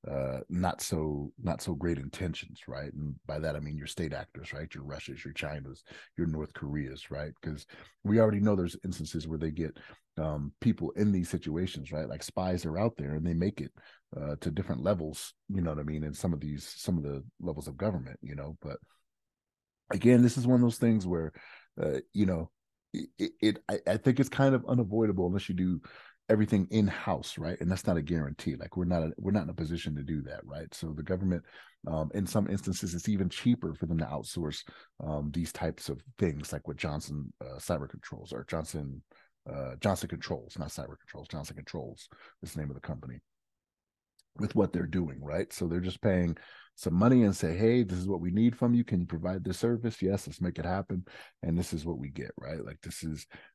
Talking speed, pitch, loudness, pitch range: 220 wpm, 85 Hz, -32 LUFS, 75-100 Hz